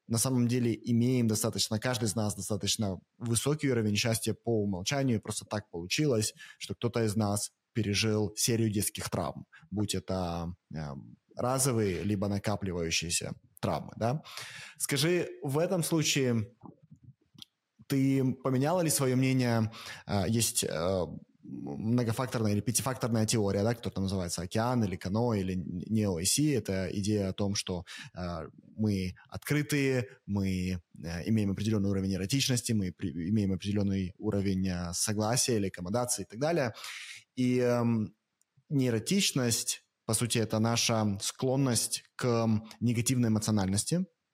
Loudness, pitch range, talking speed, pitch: -30 LUFS, 100-125 Hz, 130 wpm, 110 Hz